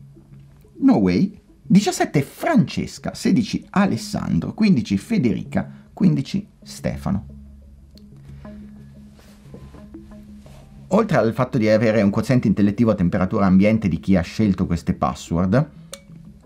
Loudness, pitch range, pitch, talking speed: -20 LUFS, 70-115 Hz, 90 Hz, 90 wpm